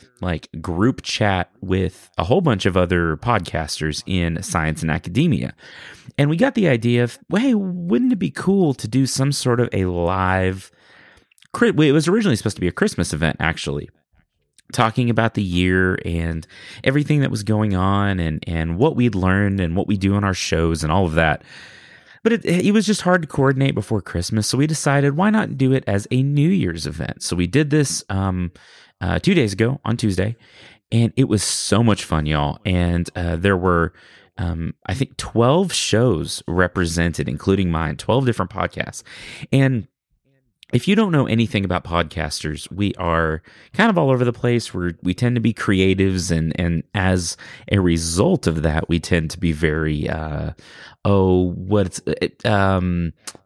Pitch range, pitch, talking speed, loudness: 85-130 Hz, 100 Hz, 185 wpm, -20 LUFS